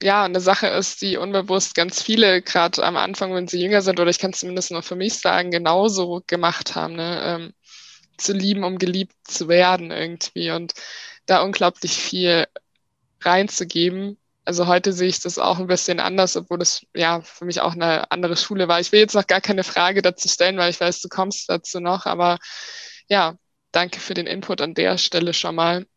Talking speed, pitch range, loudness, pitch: 200 wpm, 175-195 Hz, -20 LUFS, 180 Hz